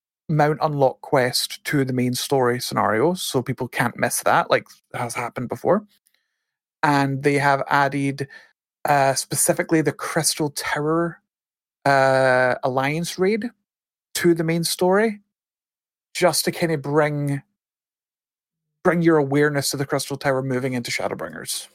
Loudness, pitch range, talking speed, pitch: -21 LUFS, 135-170 Hz, 130 wpm, 145 Hz